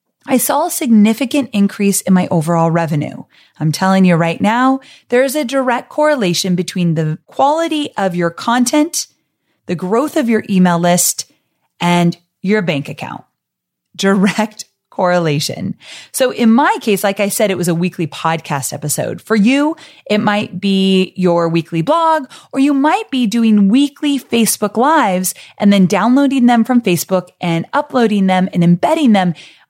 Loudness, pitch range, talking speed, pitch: -14 LUFS, 175-255 Hz, 155 wpm, 200 Hz